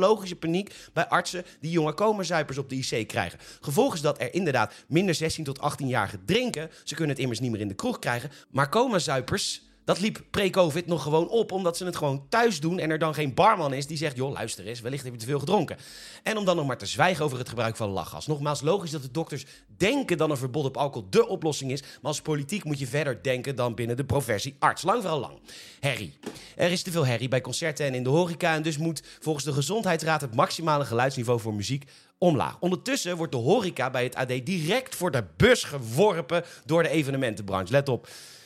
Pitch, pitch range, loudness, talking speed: 150 Hz, 130-175 Hz, -27 LUFS, 225 wpm